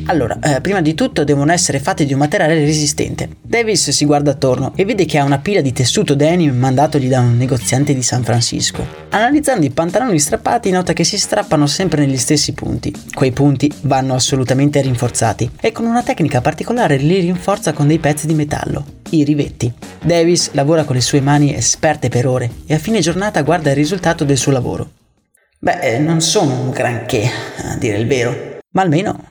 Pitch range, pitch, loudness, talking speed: 135-165 Hz, 145 Hz, -15 LUFS, 190 wpm